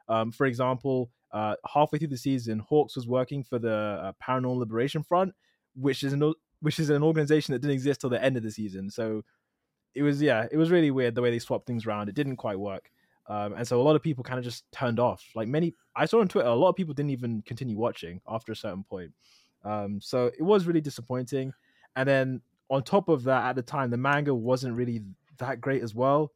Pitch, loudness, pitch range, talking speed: 130 Hz, -28 LUFS, 120-145 Hz, 240 wpm